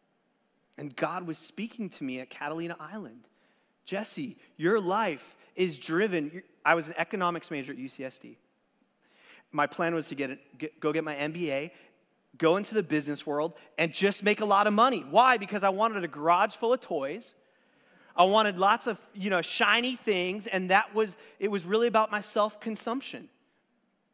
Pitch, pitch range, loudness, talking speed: 190 Hz, 160-220 Hz, -28 LUFS, 175 wpm